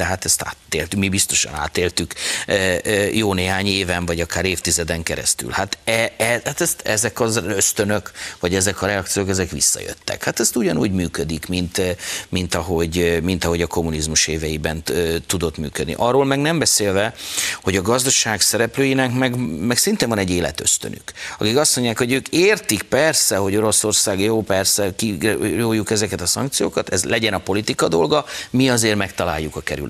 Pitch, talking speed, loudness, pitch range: 95 Hz, 170 wpm, -18 LUFS, 85-115 Hz